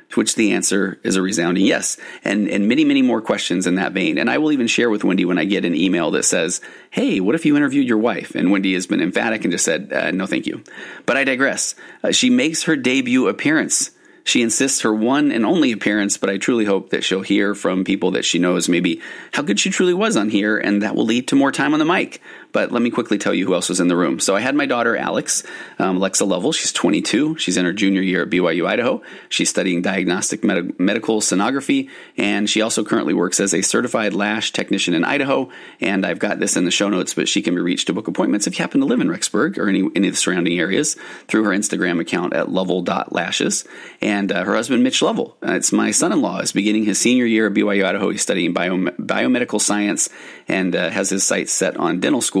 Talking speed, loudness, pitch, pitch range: 245 wpm, -18 LUFS, 105 Hz, 95-160 Hz